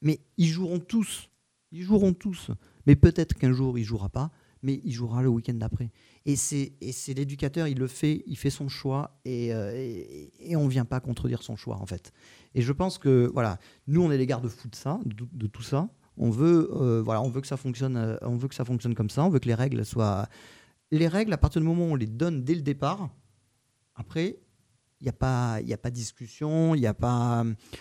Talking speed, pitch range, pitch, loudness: 235 wpm, 115-145 Hz, 130 Hz, -28 LUFS